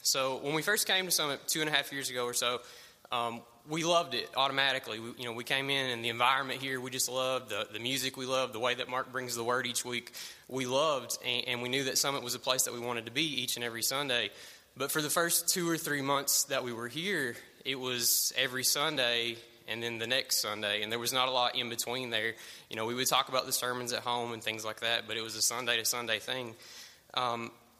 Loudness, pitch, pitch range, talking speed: -31 LUFS, 125 Hz, 120-135 Hz, 260 wpm